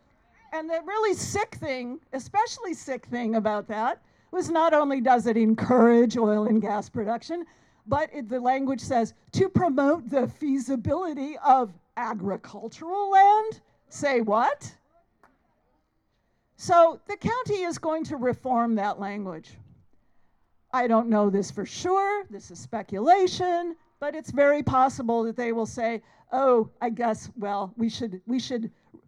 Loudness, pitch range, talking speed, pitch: -25 LUFS, 225-320 Hz, 140 wpm, 255 Hz